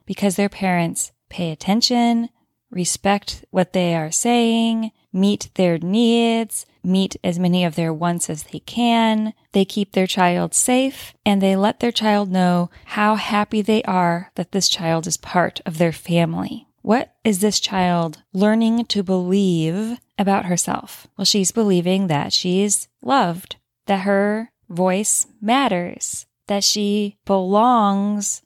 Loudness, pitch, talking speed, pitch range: -19 LUFS, 200 Hz, 140 wpm, 180-220 Hz